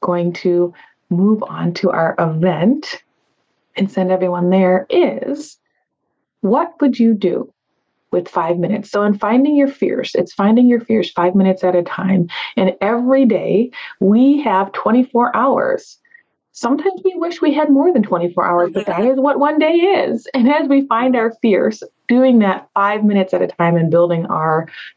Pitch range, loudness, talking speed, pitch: 180-275 Hz, -15 LUFS, 175 wpm, 215 Hz